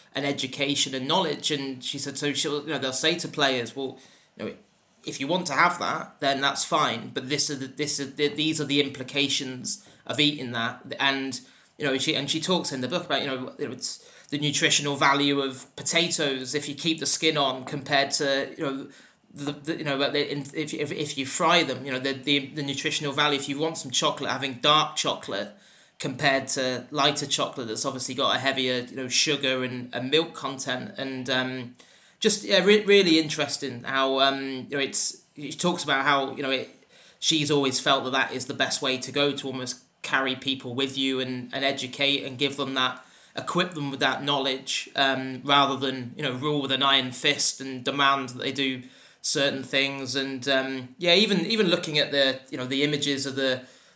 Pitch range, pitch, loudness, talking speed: 130-145 Hz, 140 Hz, -23 LUFS, 210 wpm